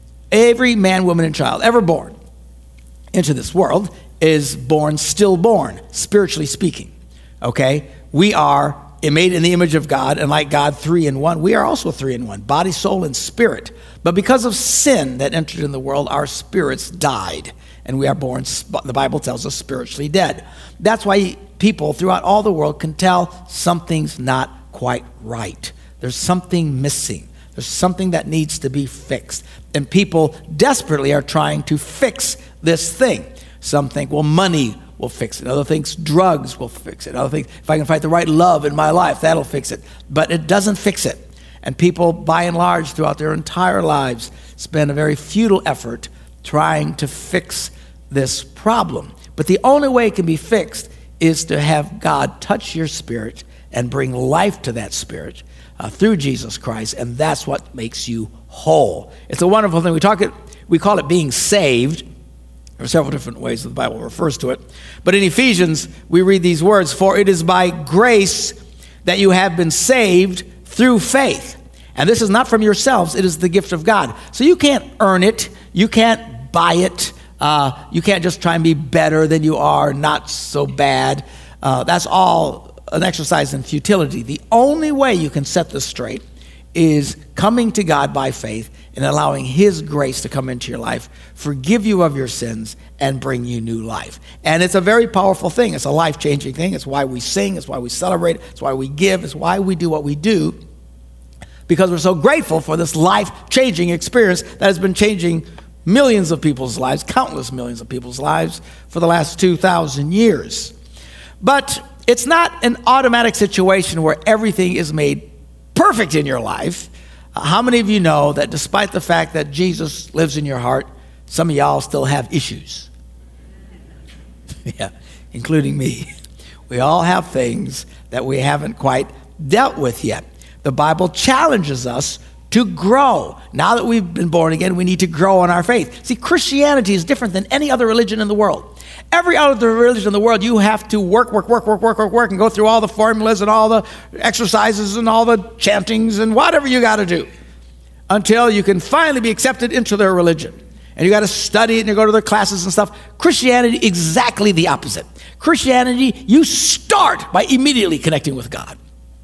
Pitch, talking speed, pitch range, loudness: 170 Hz, 190 wpm, 135-210 Hz, -15 LUFS